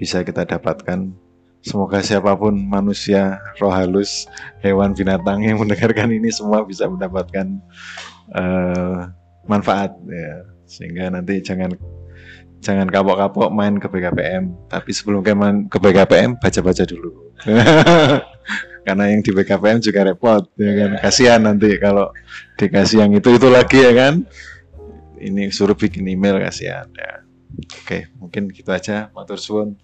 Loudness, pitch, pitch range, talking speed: -16 LUFS, 100 Hz, 90-105 Hz, 130 wpm